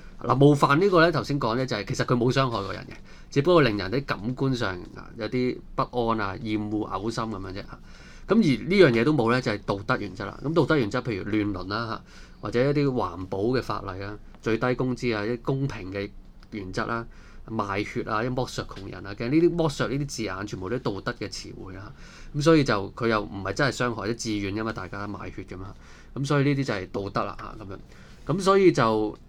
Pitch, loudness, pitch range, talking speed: 115 Hz, -25 LUFS, 100-130 Hz, 350 characters per minute